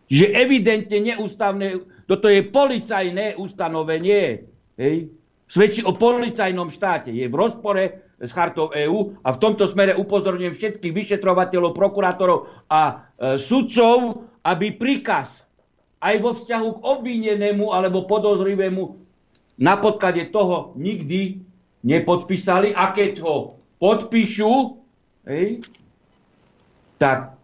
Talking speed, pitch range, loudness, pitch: 105 wpm, 175-215 Hz, -20 LUFS, 195 Hz